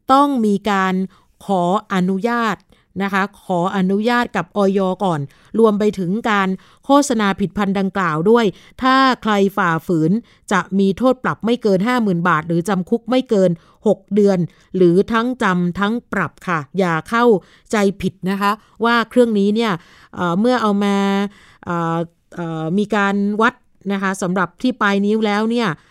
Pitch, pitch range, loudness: 200 Hz, 185-220 Hz, -18 LUFS